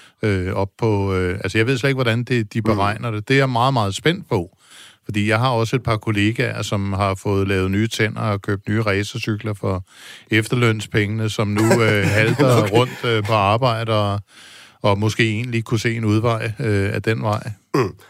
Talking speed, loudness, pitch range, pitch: 195 wpm, -19 LUFS, 105-115 Hz, 110 Hz